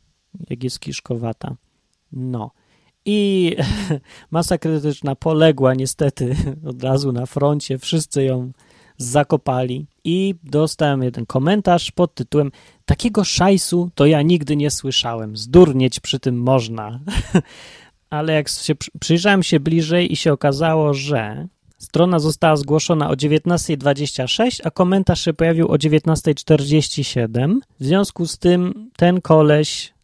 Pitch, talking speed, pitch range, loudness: 150 Hz, 120 wpm, 135-170 Hz, -18 LUFS